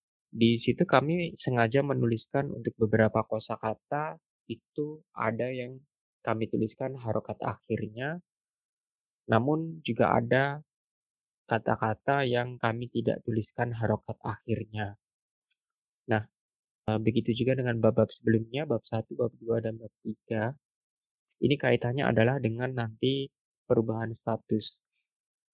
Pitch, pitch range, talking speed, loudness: 115 Hz, 110-130 Hz, 110 wpm, -30 LUFS